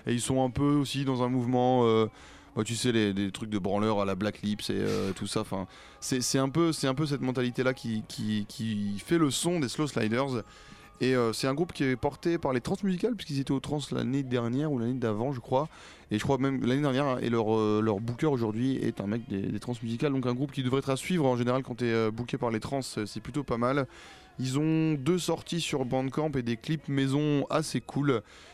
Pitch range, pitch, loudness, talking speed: 115-140 Hz, 130 Hz, -29 LUFS, 250 wpm